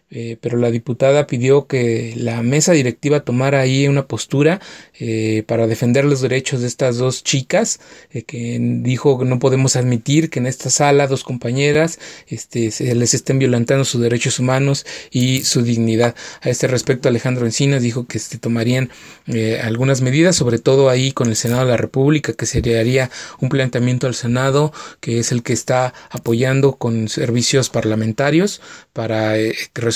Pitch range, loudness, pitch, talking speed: 120-135 Hz, -17 LUFS, 125 Hz, 175 wpm